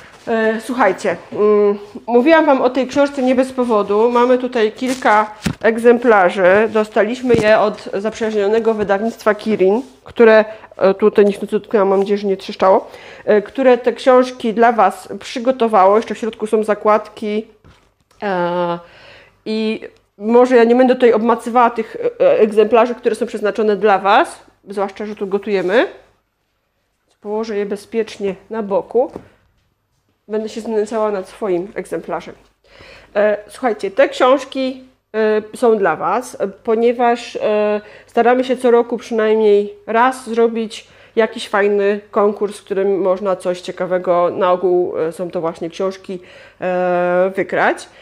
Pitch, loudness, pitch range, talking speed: 215 Hz, -16 LUFS, 200-235 Hz, 120 wpm